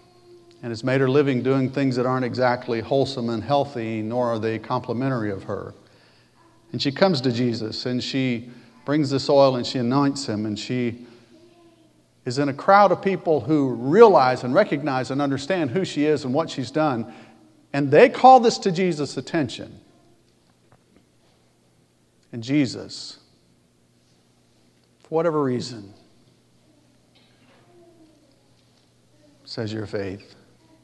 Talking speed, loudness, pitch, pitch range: 135 wpm, -21 LUFS, 125 Hz, 110-145 Hz